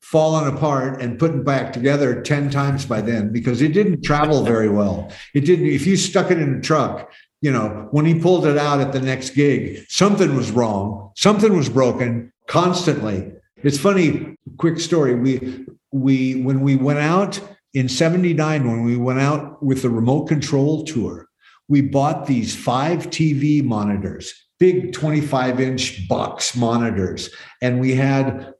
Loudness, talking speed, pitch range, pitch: -19 LUFS, 165 wpm, 125-155 Hz, 140 Hz